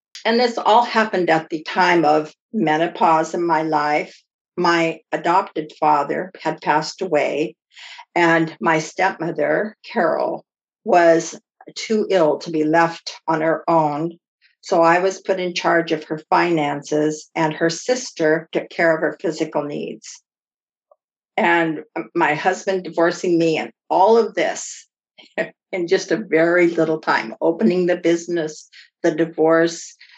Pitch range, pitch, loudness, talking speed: 160-180 Hz, 165 Hz, -19 LUFS, 135 wpm